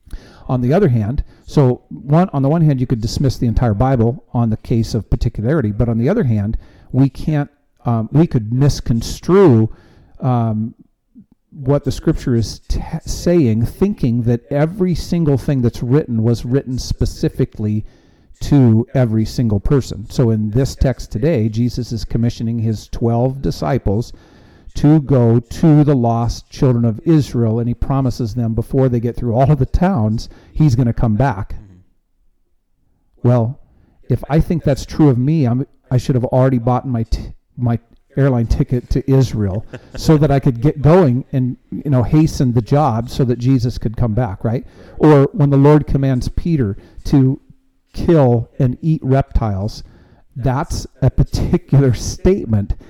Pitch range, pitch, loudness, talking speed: 115-140 Hz, 125 Hz, -16 LUFS, 165 wpm